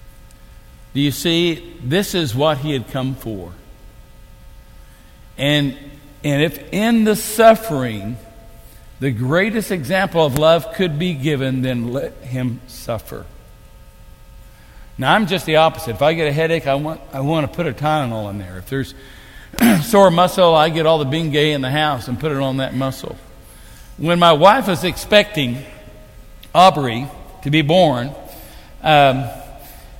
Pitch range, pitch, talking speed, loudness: 125-165 Hz, 145 Hz, 150 wpm, -17 LUFS